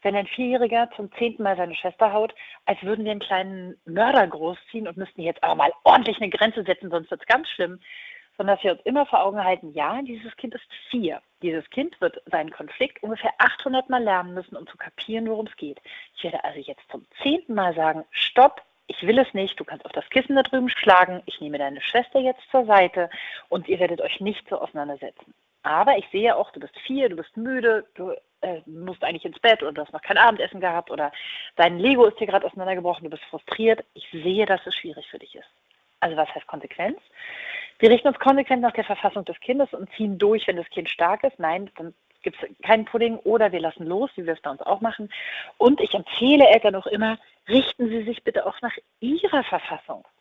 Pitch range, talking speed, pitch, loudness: 180-255 Hz, 225 wpm, 215 Hz, -22 LUFS